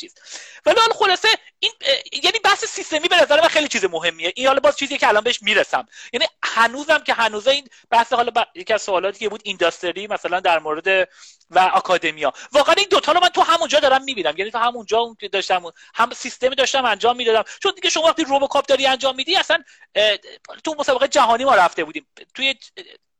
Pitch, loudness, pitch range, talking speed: 270 Hz, -18 LUFS, 210-320 Hz, 200 wpm